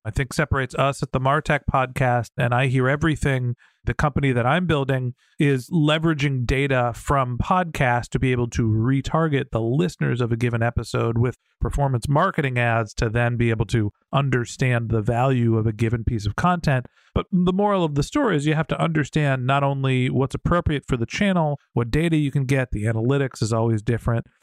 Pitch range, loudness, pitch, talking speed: 120-150 Hz, -22 LUFS, 130 Hz, 195 wpm